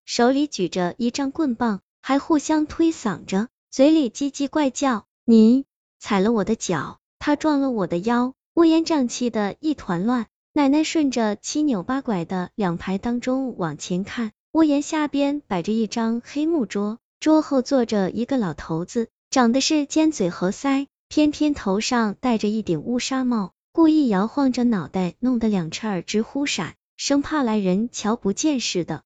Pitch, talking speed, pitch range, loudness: 240 Hz, 245 characters per minute, 205-285 Hz, -22 LUFS